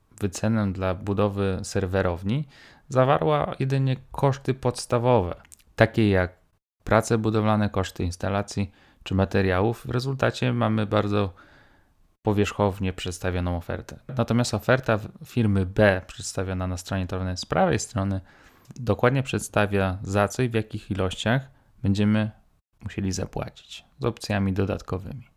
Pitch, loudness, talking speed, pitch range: 105 Hz, -25 LUFS, 115 wpm, 95-120 Hz